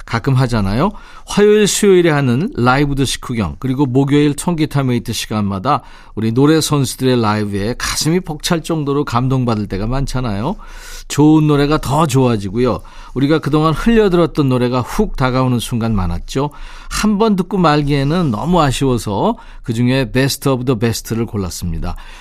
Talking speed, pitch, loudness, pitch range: 365 characters per minute, 135 Hz, -15 LUFS, 115-155 Hz